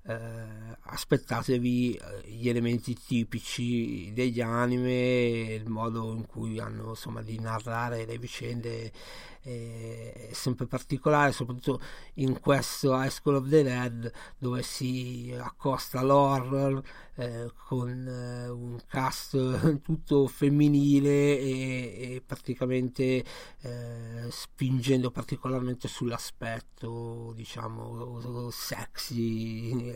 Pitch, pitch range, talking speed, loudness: 125 Hz, 115-130 Hz, 95 wpm, -30 LUFS